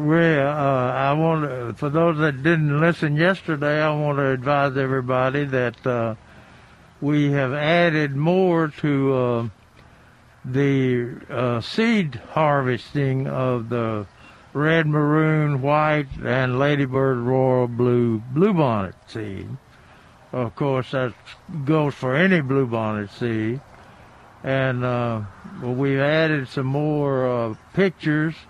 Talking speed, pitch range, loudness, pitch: 115 wpm, 125-150 Hz, -21 LUFS, 135 Hz